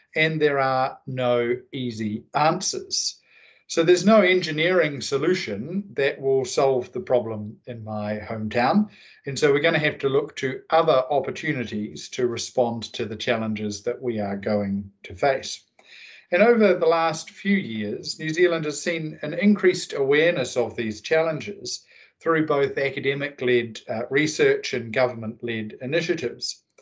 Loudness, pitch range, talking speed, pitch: -23 LUFS, 120-180 Hz, 150 wpm, 140 Hz